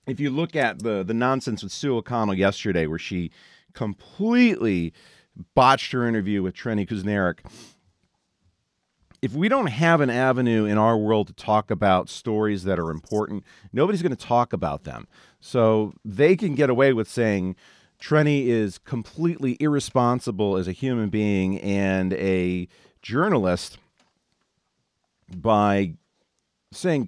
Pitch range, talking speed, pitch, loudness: 95-130 Hz, 135 wpm, 110 Hz, -23 LUFS